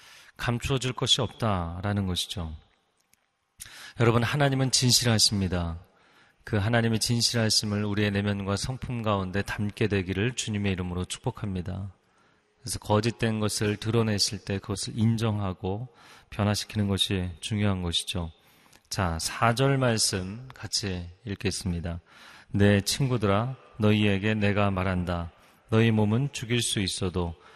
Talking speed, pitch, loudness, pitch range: 290 characters per minute, 105 Hz, -27 LUFS, 95-115 Hz